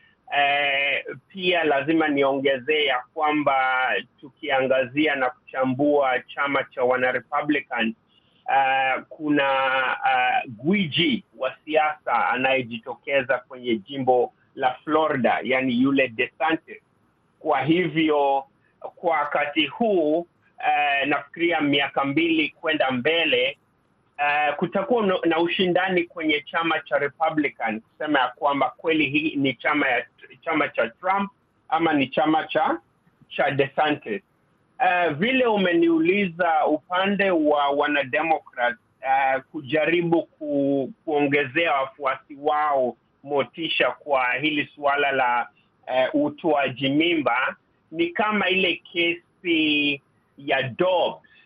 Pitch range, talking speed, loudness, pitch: 135-170 Hz, 100 wpm, -22 LUFS, 150 Hz